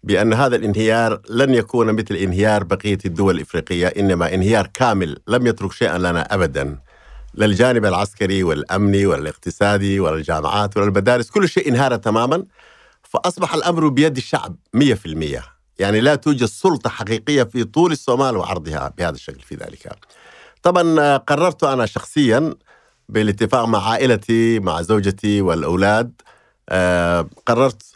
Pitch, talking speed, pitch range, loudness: 110 Hz, 120 wpm, 95-125 Hz, -18 LUFS